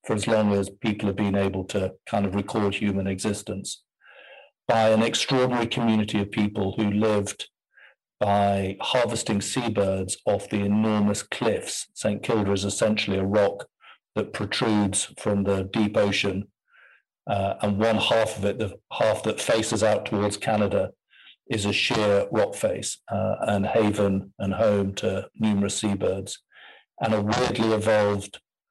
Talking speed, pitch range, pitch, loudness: 150 wpm, 100-110 Hz, 105 Hz, -24 LUFS